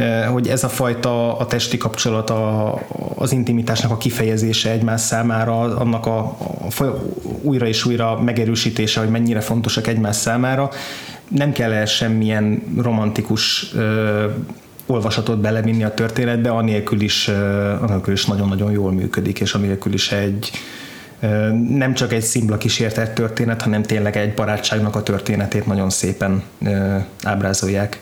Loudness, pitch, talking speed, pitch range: -19 LUFS, 110 Hz, 140 wpm, 105-115 Hz